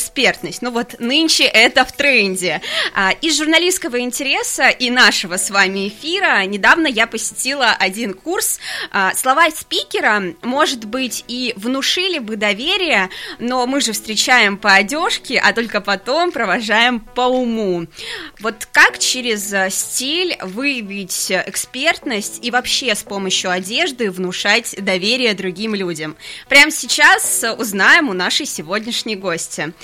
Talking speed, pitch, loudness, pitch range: 125 wpm, 235 Hz, -15 LUFS, 200-280 Hz